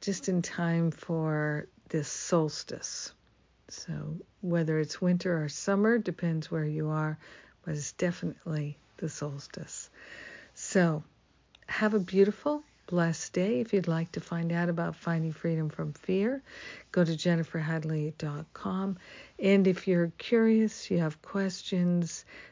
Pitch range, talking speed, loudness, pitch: 160-190 Hz, 130 wpm, -31 LUFS, 170 Hz